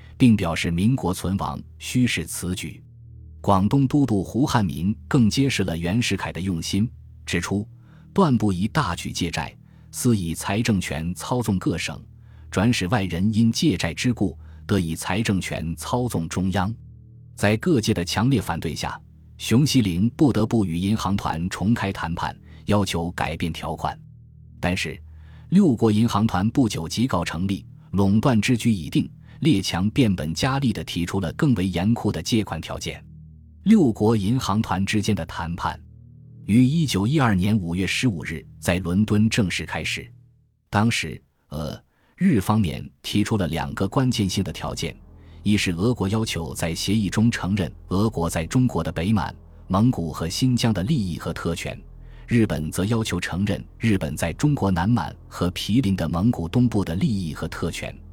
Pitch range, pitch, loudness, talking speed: 85-115 Hz, 100 Hz, -23 LUFS, 235 characters per minute